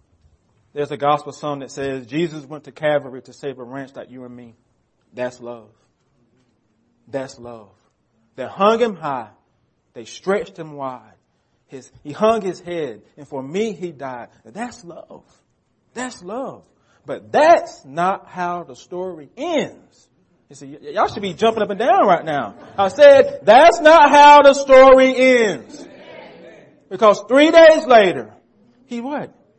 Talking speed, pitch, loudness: 155 wpm, 155 Hz, -14 LUFS